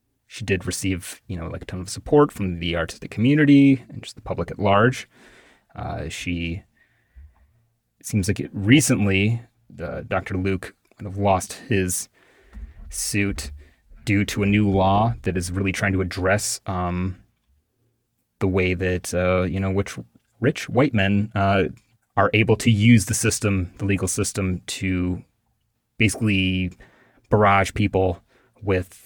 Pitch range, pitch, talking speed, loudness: 90-115 Hz, 100 Hz, 150 wpm, -22 LUFS